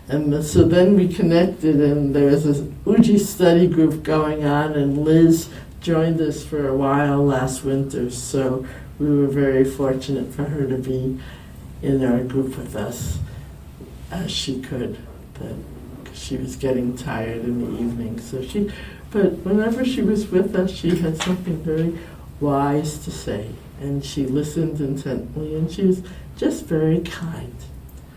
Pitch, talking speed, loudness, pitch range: 145 Hz, 155 wpm, -20 LUFS, 130-165 Hz